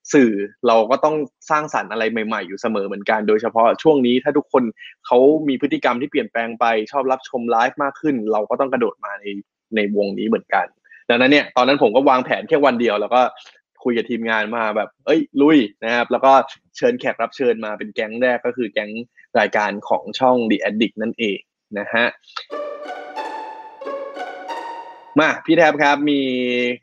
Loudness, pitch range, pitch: -18 LUFS, 110-145 Hz, 125 Hz